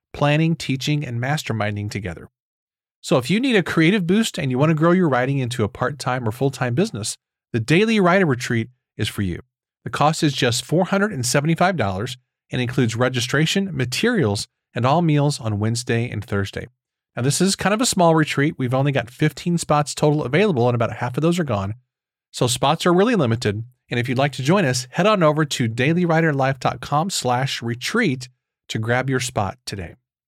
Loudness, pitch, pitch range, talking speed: -20 LUFS, 130 Hz, 120-160 Hz, 180 wpm